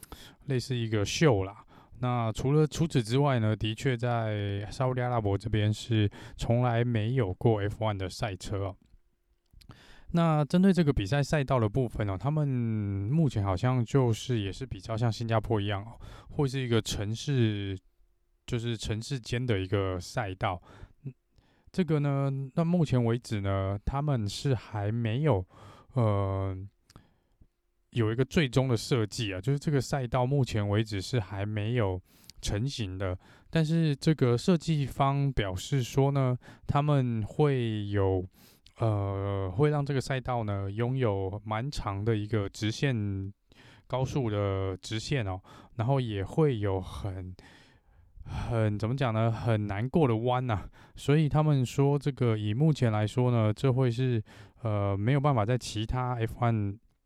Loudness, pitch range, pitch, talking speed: -29 LUFS, 100-135 Hz, 115 Hz, 220 characters per minute